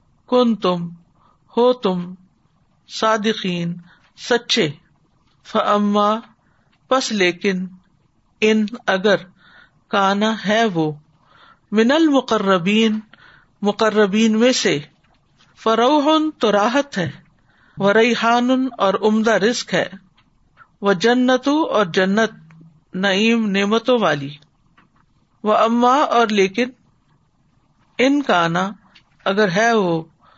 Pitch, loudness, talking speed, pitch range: 210 Hz, -18 LUFS, 90 wpm, 180-230 Hz